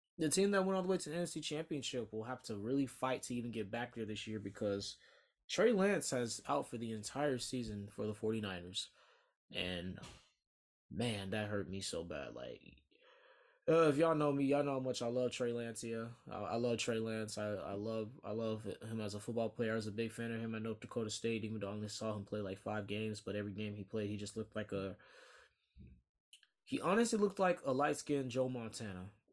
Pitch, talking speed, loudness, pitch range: 115 Hz, 230 wpm, -39 LUFS, 105-130 Hz